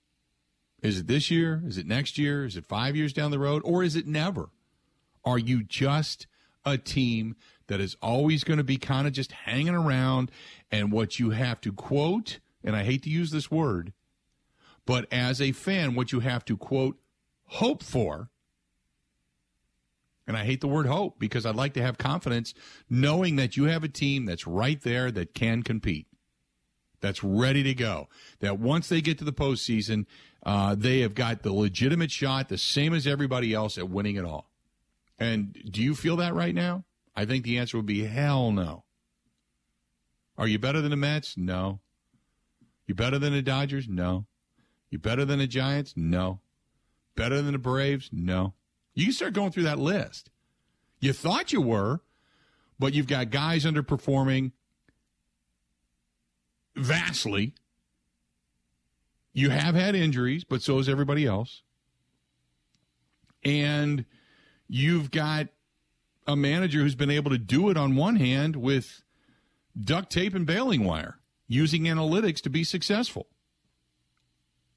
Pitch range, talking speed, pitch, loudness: 95-145 Hz, 160 wpm, 125 Hz, -27 LUFS